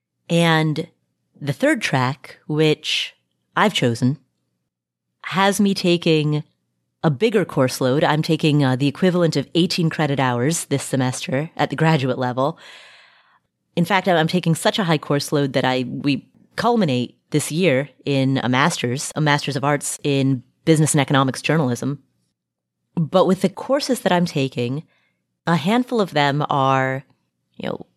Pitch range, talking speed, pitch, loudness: 130-170 Hz, 150 wpm, 145 Hz, -20 LUFS